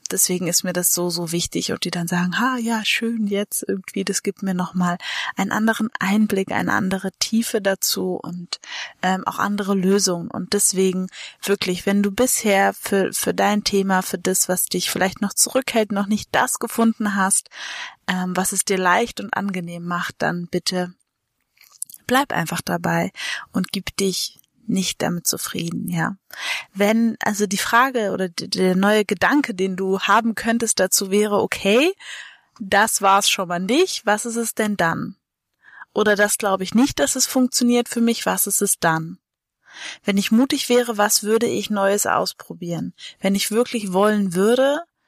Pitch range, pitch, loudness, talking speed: 185-225 Hz, 200 Hz, -20 LUFS, 170 wpm